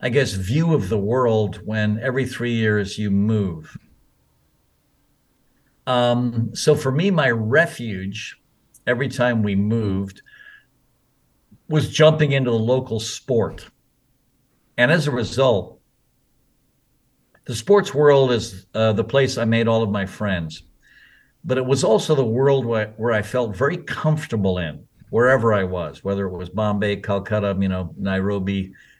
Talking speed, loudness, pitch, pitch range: 145 wpm, -20 LUFS, 115 Hz, 100-135 Hz